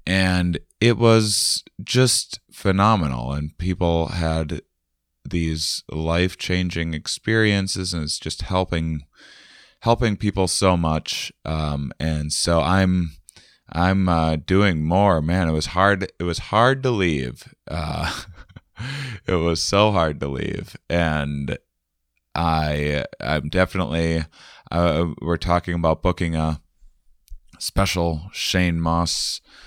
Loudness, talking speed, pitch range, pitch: -21 LUFS, 115 wpm, 80-95 Hz, 85 Hz